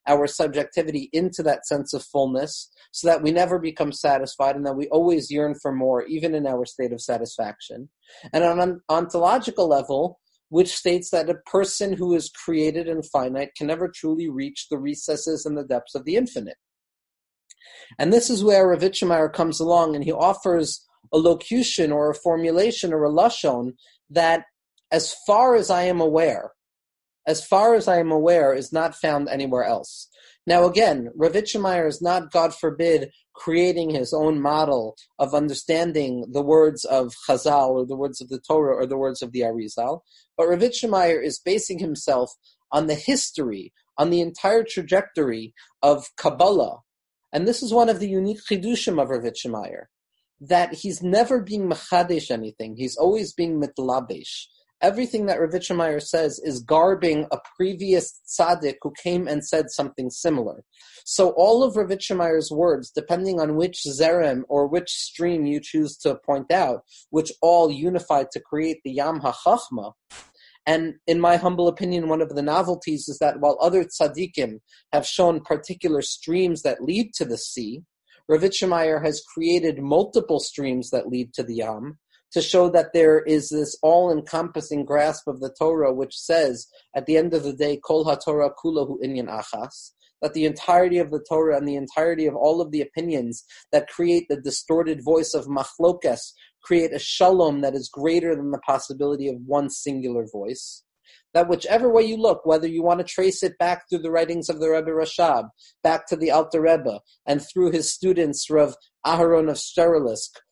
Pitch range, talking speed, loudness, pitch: 145-175 Hz, 170 wpm, -22 LUFS, 160 Hz